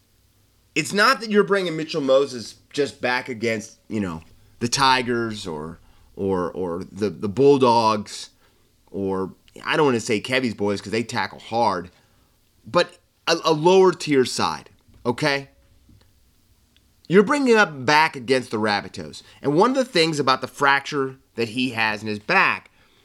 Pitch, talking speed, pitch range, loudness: 120 Hz, 155 wpm, 100-145 Hz, -21 LUFS